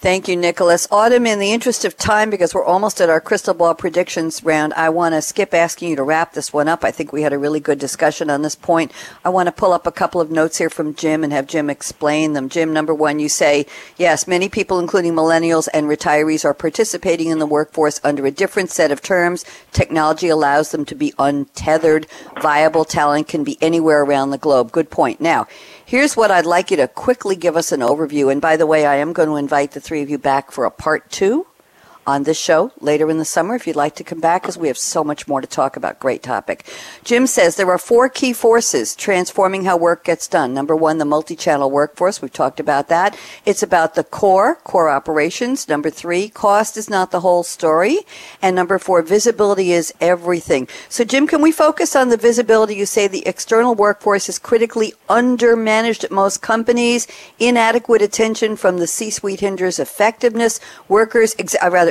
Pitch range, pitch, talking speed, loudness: 155-210 Hz, 175 Hz, 215 wpm, -16 LUFS